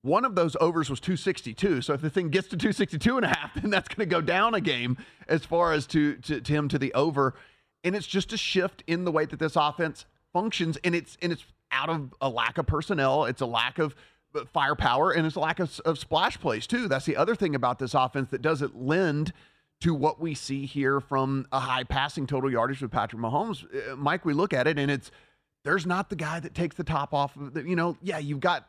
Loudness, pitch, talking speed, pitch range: -27 LUFS, 160 Hz, 245 wpm, 140-180 Hz